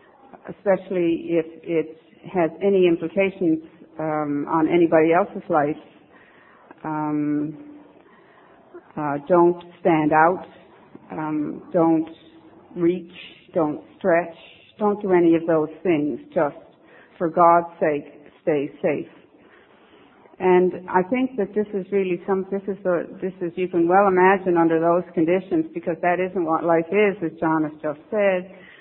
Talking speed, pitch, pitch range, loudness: 135 wpm, 170 Hz, 160-190 Hz, -21 LUFS